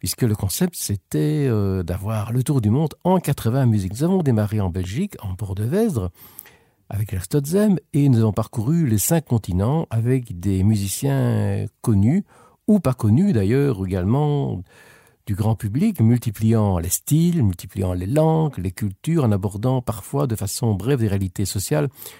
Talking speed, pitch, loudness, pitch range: 160 wpm, 115 Hz, -21 LUFS, 100-145 Hz